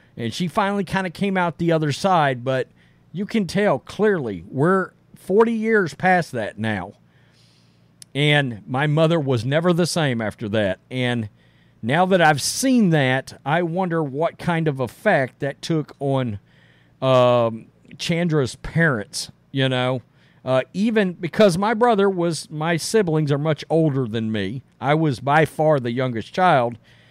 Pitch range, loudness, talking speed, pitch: 125-180 Hz, -21 LUFS, 155 wpm, 155 Hz